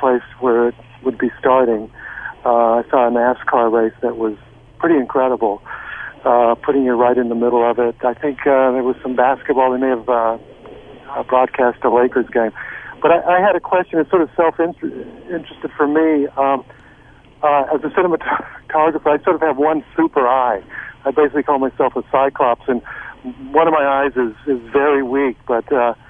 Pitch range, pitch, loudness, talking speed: 120-150 Hz, 130 Hz, -16 LUFS, 190 wpm